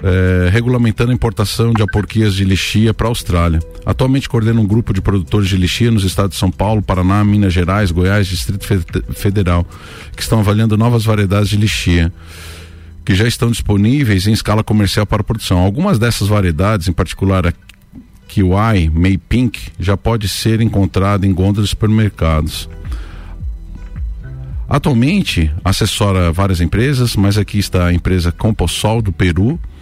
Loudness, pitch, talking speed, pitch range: -14 LUFS, 100 Hz, 155 wpm, 90-110 Hz